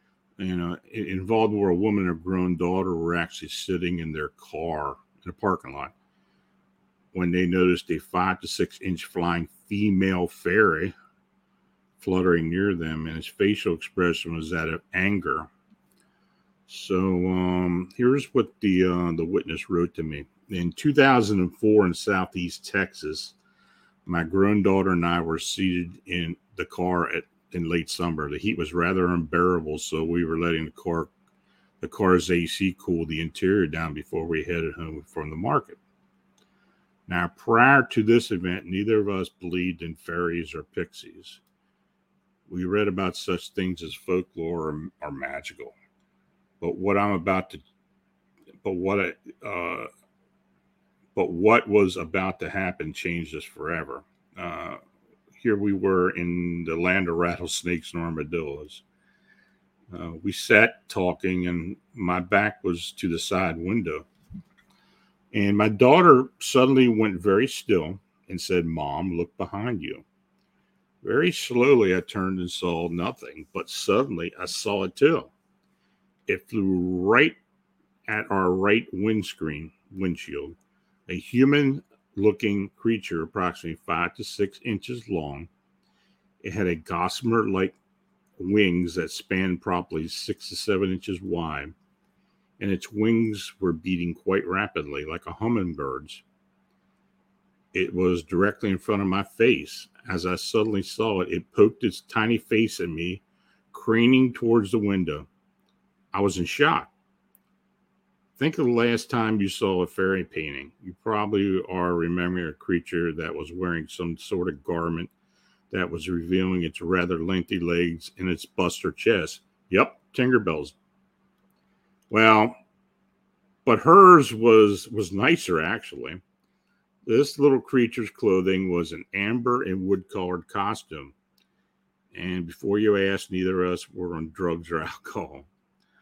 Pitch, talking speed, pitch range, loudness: 90 Hz, 140 wpm, 85-105 Hz, -24 LUFS